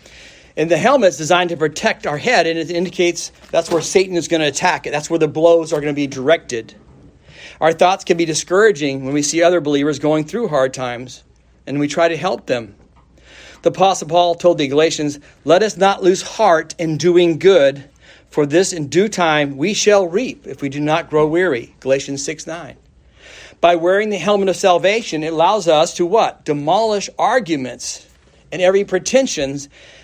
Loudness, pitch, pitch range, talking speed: -16 LUFS, 165 Hz, 145-185 Hz, 190 wpm